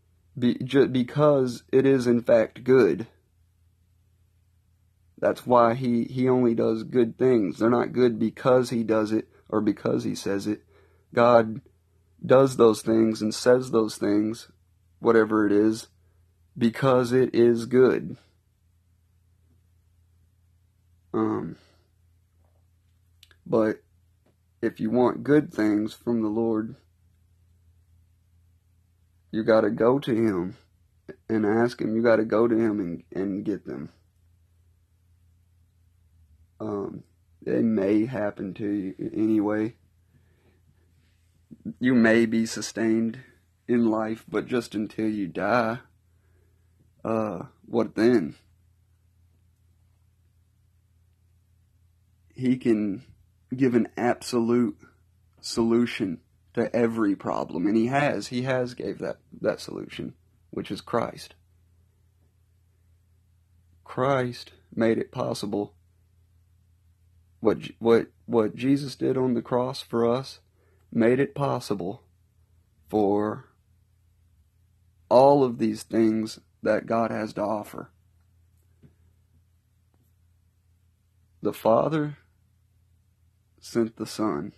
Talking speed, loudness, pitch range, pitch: 100 wpm, -24 LUFS, 90-115 Hz, 95 Hz